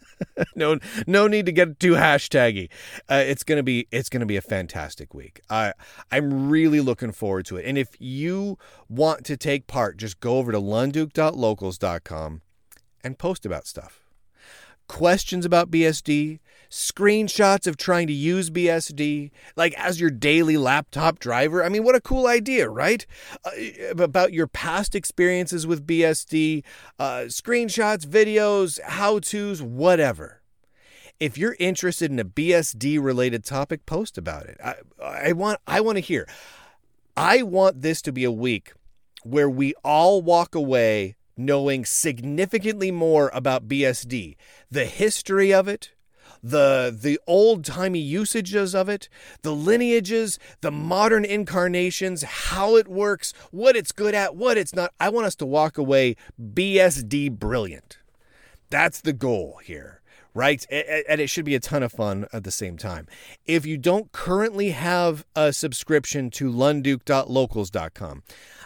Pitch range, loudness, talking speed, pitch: 130-185 Hz, -22 LUFS, 150 wpm, 155 Hz